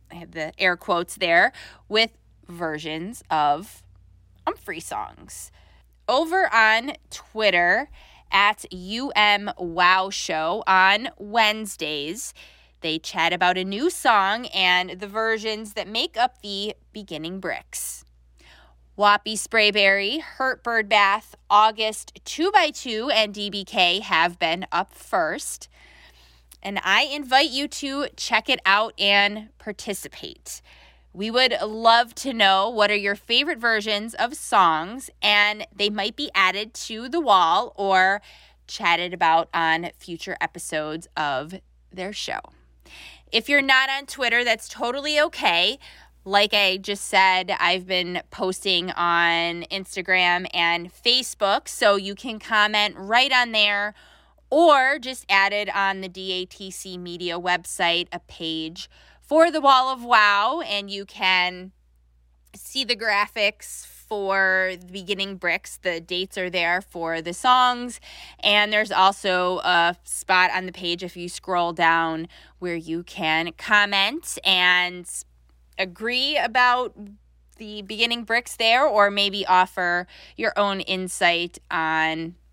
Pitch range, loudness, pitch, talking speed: 170-220 Hz, -21 LUFS, 195 Hz, 125 wpm